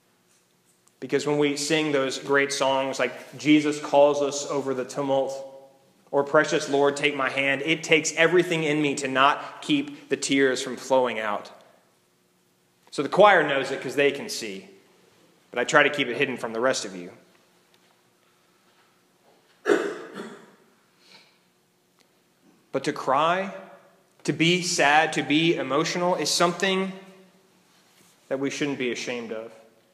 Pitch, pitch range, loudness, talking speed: 140 Hz, 125-150 Hz, -23 LUFS, 140 wpm